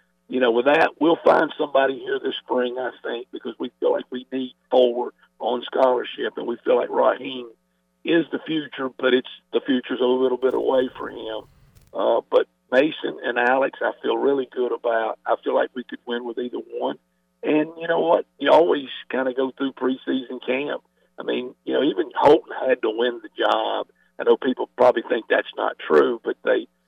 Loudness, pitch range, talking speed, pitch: -22 LUFS, 125-170 Hz, 205 wpm, 130 Hz